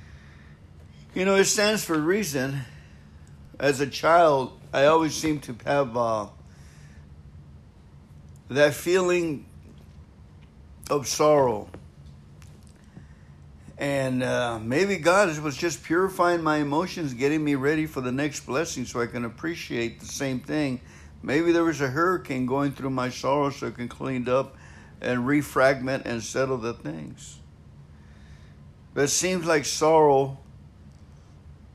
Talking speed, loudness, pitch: 130 wpm, -24 LUFS, 125 Hz